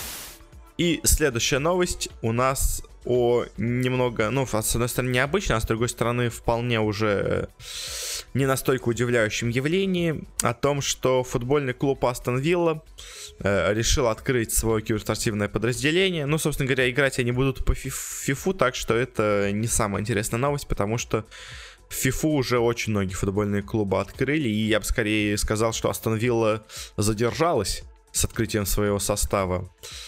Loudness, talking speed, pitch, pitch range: -24 LUFS, 145 wpm, 120 Hz, 110-135 Hz